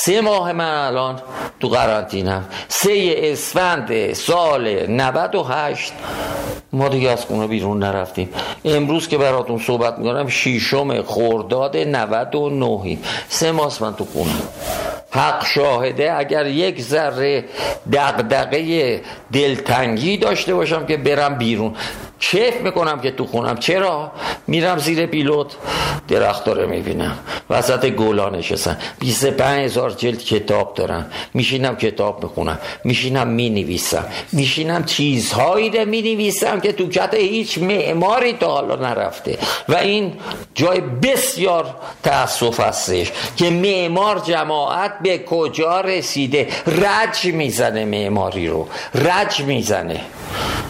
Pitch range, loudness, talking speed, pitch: 120-180 Hz, -18 LUFS, 115 wpm, 145 Hz